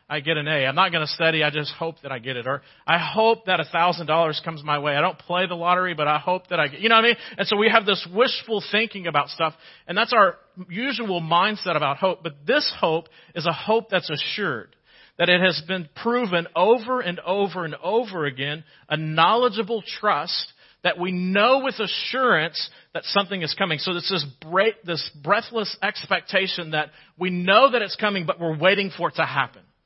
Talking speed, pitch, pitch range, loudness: 215 wpm, 180 Hz, 160-205 Hz, -22 LUFS